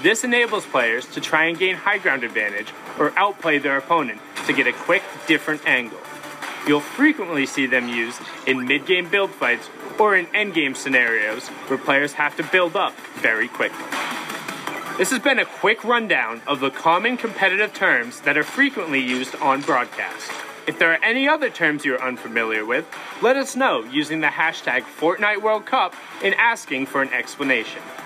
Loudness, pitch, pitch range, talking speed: -20 LUFS, 165 Hz, 140-210 Hz, 175 wpm